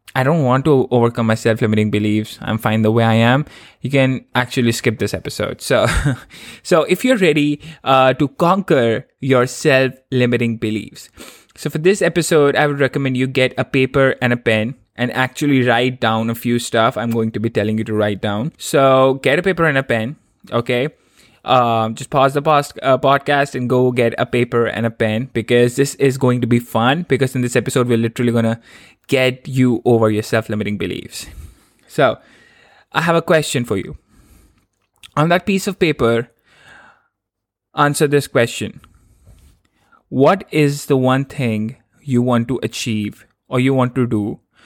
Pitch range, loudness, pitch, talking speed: 115-140 Hz, -16 LUFS, 125 Hz, 180 wpm